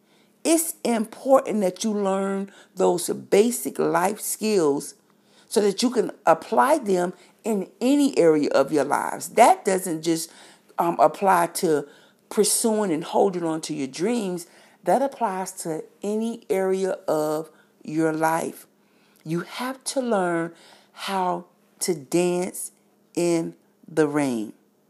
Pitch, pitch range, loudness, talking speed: 190 Hz, 165-215 Hz, -23 LUFS, 125 wpm